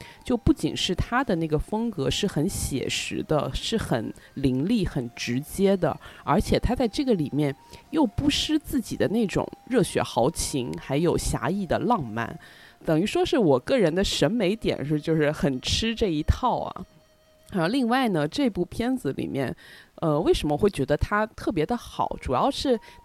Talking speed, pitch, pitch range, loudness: 250 characters per minute, 190 Hz, 150-245 Hz, -25 LUFS